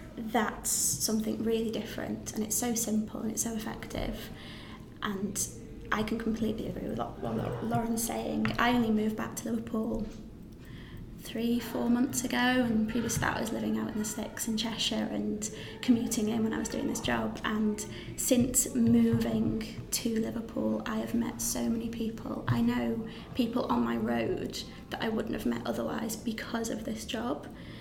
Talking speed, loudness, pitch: 175 wpm, -31 LUFS, 225 Hz